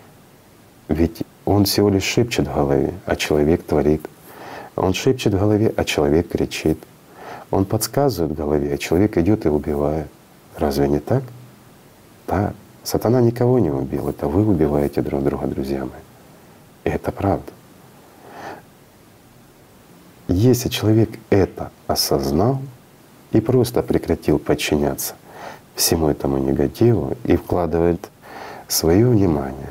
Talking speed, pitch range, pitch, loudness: 120 wpm, 75-110 Hz, 95 Hz, -19 LUFS